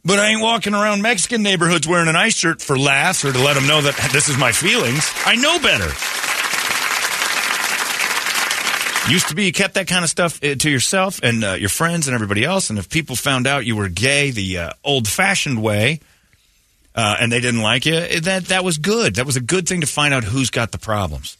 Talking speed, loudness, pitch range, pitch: 220 wpm, -16 LUFS, 125-185 Hz, 145 Hz